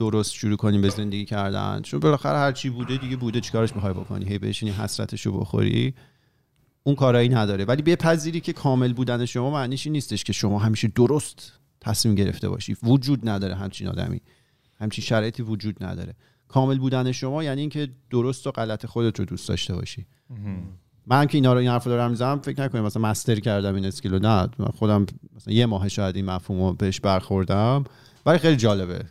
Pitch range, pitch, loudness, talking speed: 100-130 Hz, 115 Hz, -24 LUFS, 175 wpm